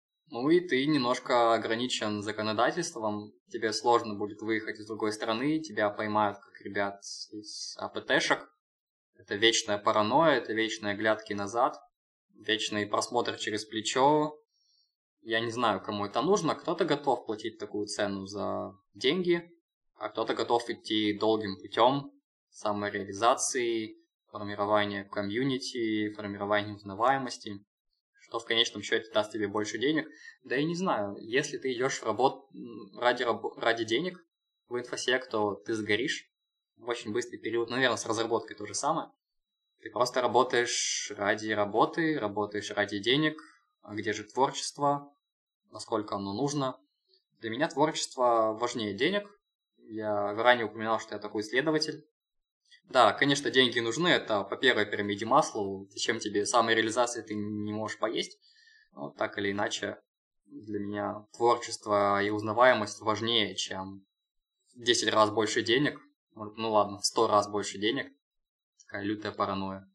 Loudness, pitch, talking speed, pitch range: -29 LUFS, 110 Hz, 140 wpm, 105-135 Hz